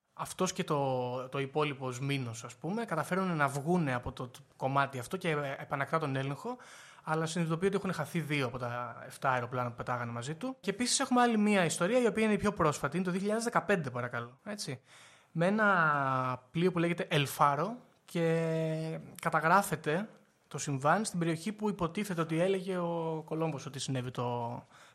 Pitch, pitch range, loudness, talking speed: 160 Hz, 135-190 Hz, -32 LUFS, 170 wpm